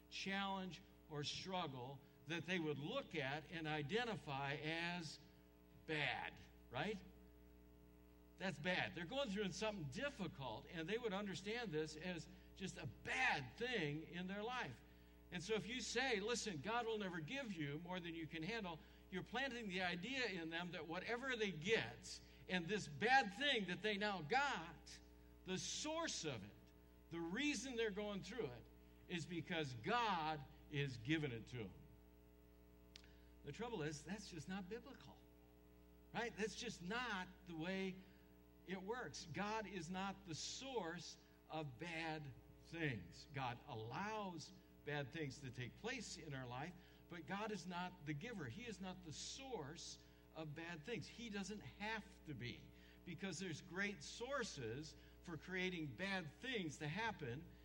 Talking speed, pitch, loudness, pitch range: 155 wpm, 165 Hz, -47 LUFS, 130-200 Hz